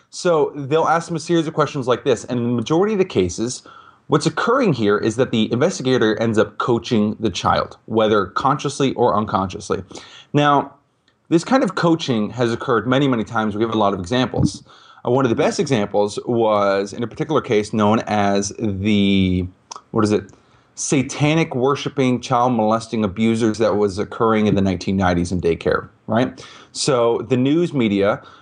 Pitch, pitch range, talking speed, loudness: 115 Hz, 105-135 Hz, 175 wpm, -19 LUFS